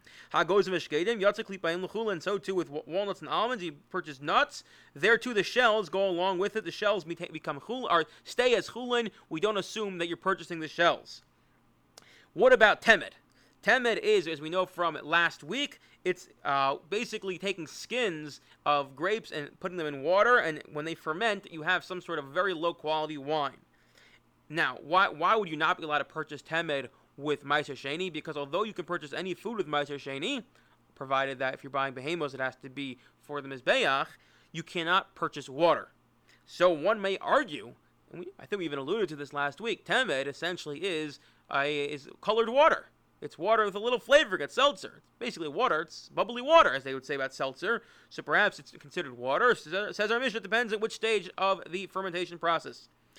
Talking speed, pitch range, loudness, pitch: 190 wpm, 145-205 Hz, -29 LUFS, 170 Hz